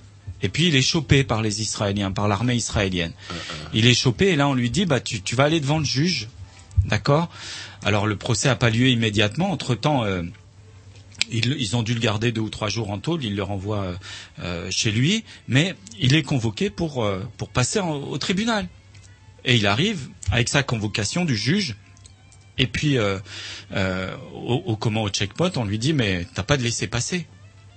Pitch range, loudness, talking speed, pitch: 100-135 Hz, -22 LUFS, 200 wpm, 110 Hz